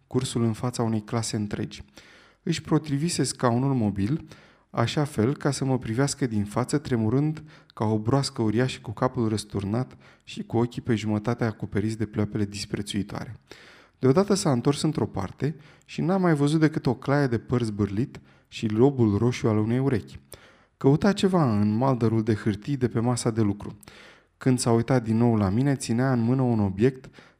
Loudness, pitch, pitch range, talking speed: -25 LUFS, 120 Hz, 110-135 Hz, 175 wpm